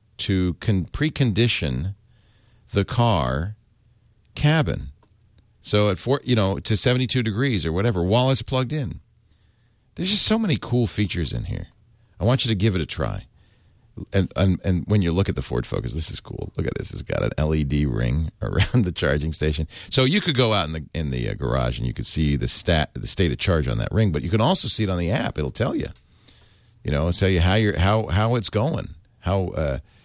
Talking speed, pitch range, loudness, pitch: 220 wpm, 85-115 Hz, -22 LUFS, 105 Hz